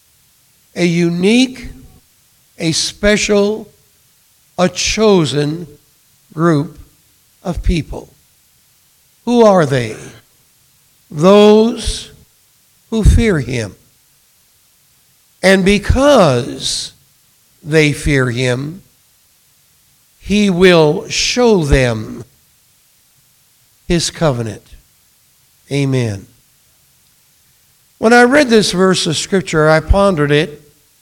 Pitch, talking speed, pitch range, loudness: 150 Hz, 75 wpm, 135-195 Hz, -13 LUFS